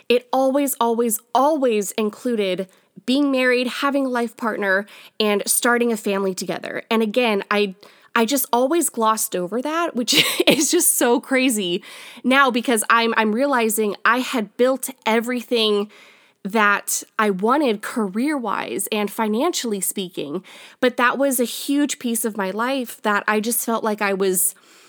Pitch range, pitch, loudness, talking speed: 210-260 Hz, 230 Hz, -20 LUFS, 150 wpm